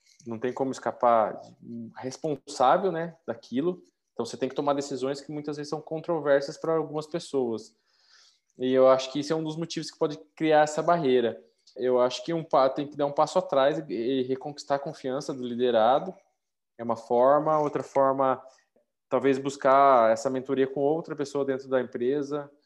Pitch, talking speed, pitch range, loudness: 140 Hz, 175 wpm, 130-155 Hz, -26 LUFS